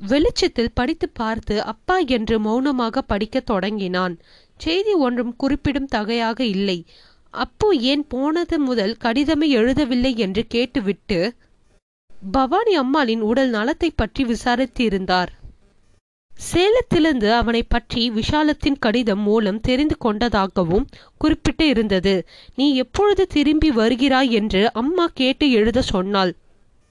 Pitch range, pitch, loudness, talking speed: 220-295 Hz, 245 Hz, -19 LUFS, 105 wpm